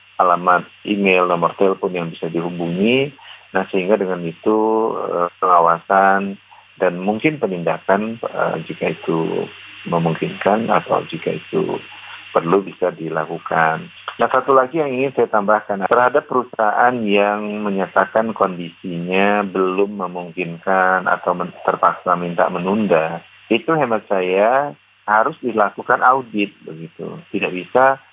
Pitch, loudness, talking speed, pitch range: 100 Hz, -18 LUFS, 115 wpm, 90-110 Hz